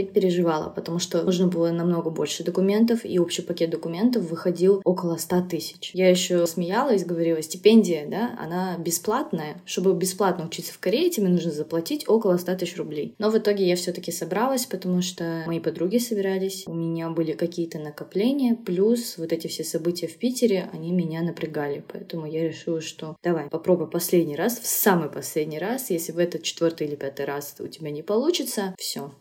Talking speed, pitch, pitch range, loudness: 175 wpm, 175 Hz, 165-195 Hz, -24 LUFS